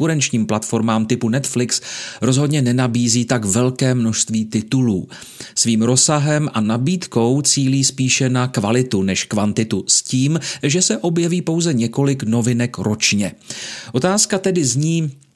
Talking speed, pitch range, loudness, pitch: 125 wpm, 115-150 Hz, -17 LUFS, 125 Hz